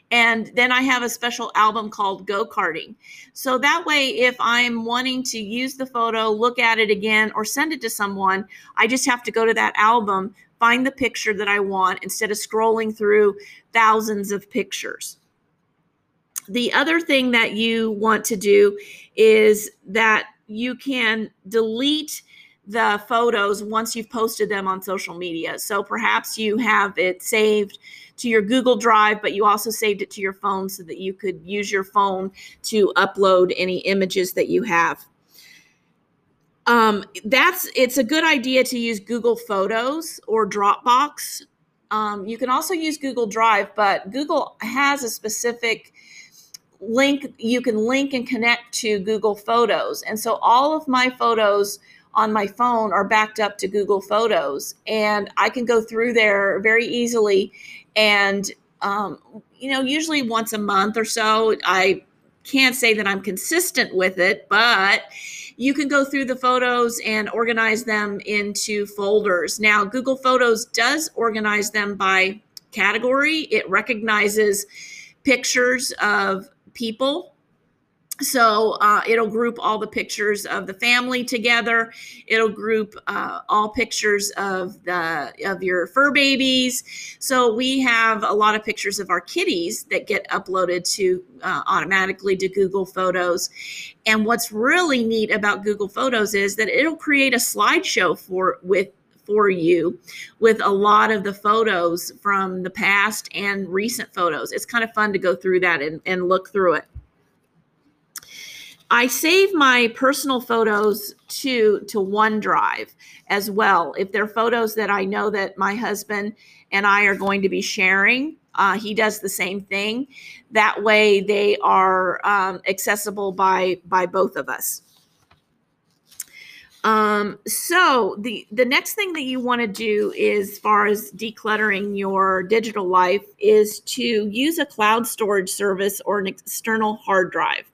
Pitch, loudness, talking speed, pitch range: 215 Hz, -19 LUFS, 155 wpm, 200-240 Hz